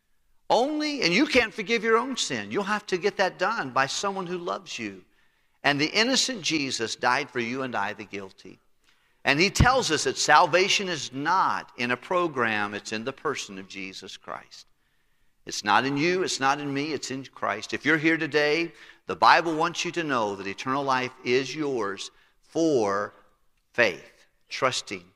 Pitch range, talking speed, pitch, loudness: 105-180 Hz, 185 wpm, 140 Hz, -25 LUFS